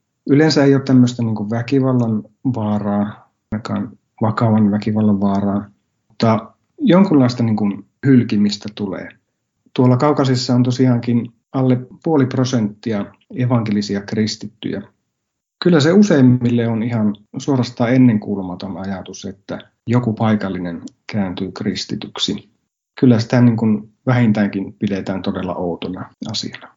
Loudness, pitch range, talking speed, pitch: -17 LUFS, 105-125 Hz, 105 wpm, 110 Hz